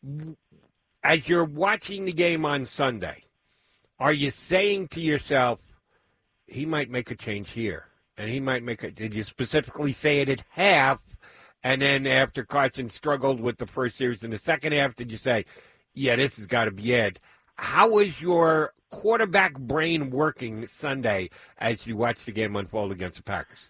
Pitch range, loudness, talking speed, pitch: 115-155 Hz, -25 LUFS, 175 wpm, 135 Hz